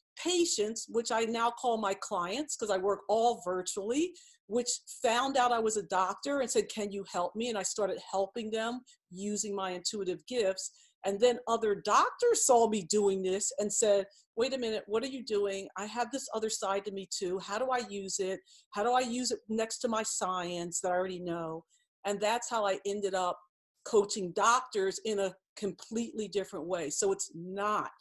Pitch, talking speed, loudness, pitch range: 210 Hz, 200 wpm, -32 LUFS, 195-235 Hz